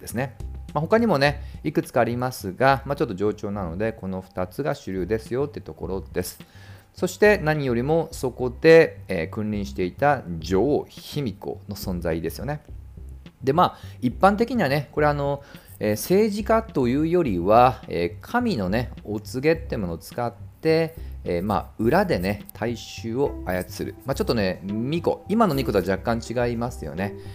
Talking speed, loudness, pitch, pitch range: 325 characters per minute, -24 LUFS, 115 Hz, 95-145 Hz